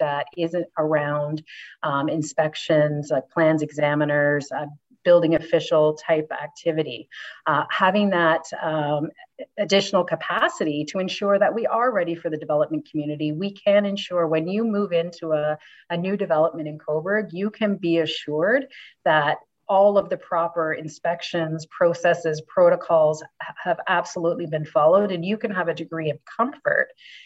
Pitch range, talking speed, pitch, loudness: 155-195 Hz, 145 wpm, 165 Hz, -22 LUFS